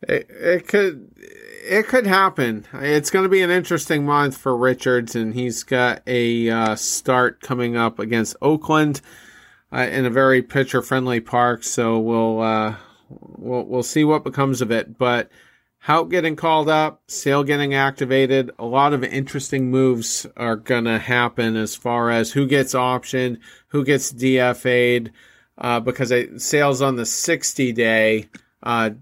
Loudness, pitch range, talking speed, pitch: -19 LUFS, 120-145 Hz, 160 wpm, 130 Hz